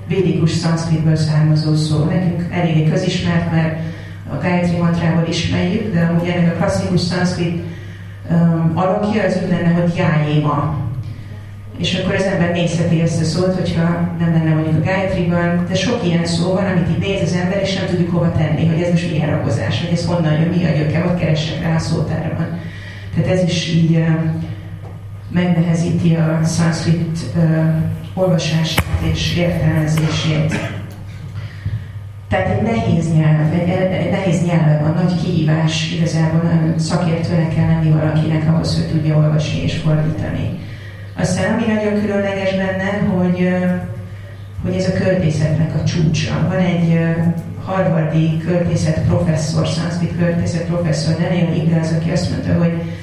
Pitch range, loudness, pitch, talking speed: 155-175 Hz, -17 LUFS, 165 Hz, 150 wpm